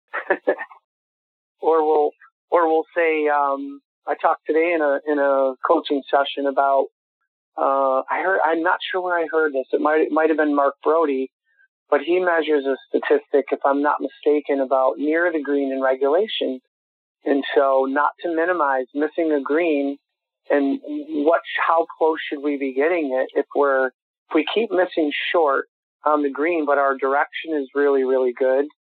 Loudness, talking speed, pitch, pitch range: -20 LUFS, 175 wpm, 145 Hz, 140-160 Hz